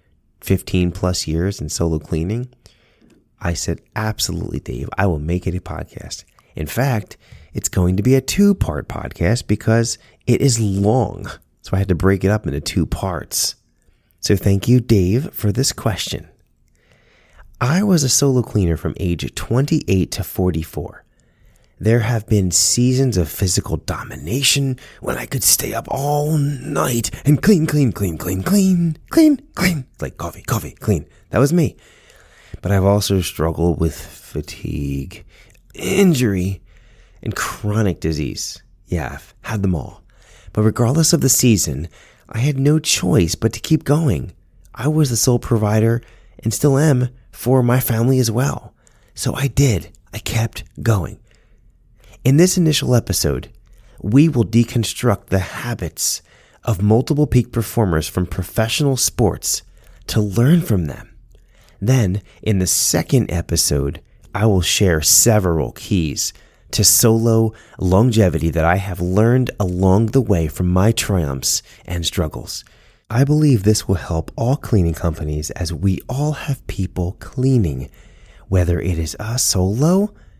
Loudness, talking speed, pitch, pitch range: -18 LUFS, 150 wpm, 105 Hz, 90-125 Hz